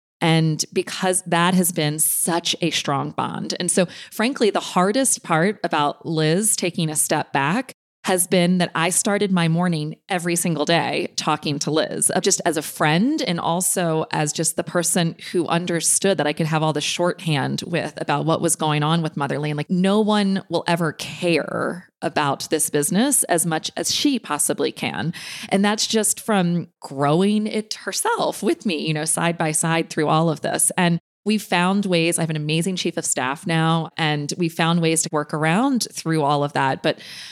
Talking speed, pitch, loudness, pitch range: 190 wpm, 170 Hz, -20 LUFS, 155-185 Hz